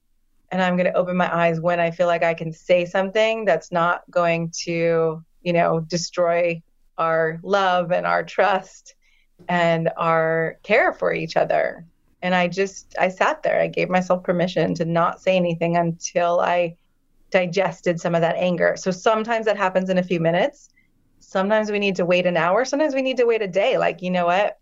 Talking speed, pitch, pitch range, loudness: 195 wpm, 175 Hz, 165-185 Hz, -21 LUFS